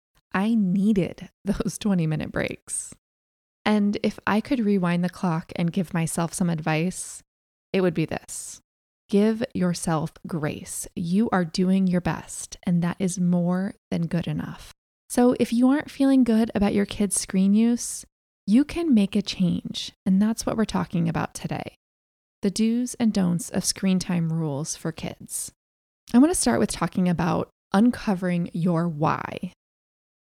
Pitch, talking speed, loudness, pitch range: 185 Hz, 155 wpm, -24 LUFS, 170-215 Hz